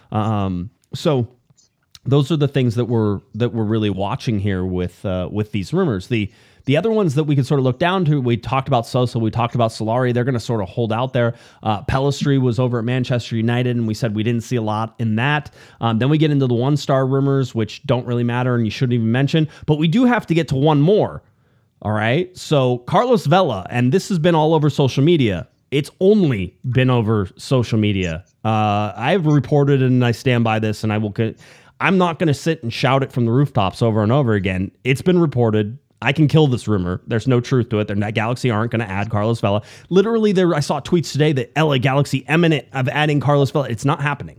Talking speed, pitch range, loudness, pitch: 235 wpm, 110-145 Hz, -18 LUFS, 125 Hz